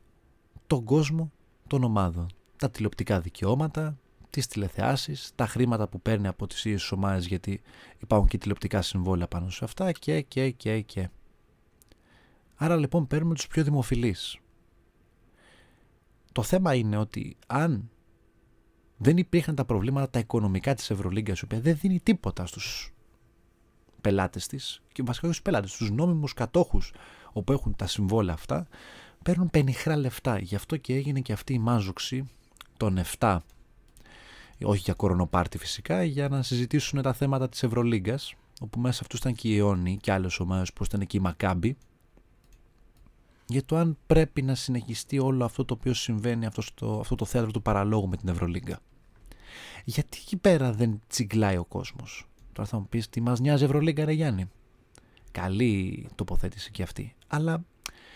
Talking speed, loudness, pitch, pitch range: 155 wpm, -28 LUFS, 115 Hz, 100-135 Hz